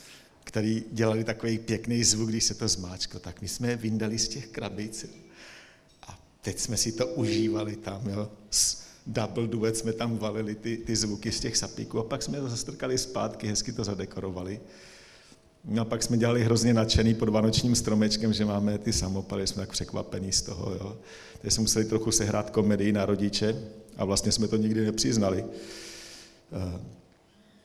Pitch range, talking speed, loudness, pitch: 100-115 Hz, 170 wpm, -28 LUFS, 110 Hz